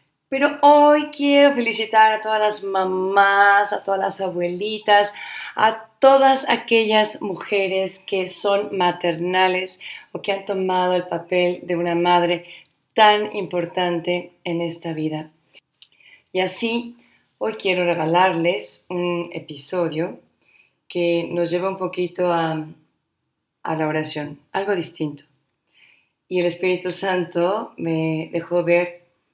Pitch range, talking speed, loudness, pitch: 170-205 Hz, 120 wpm, -20 LUFS, 180 Hz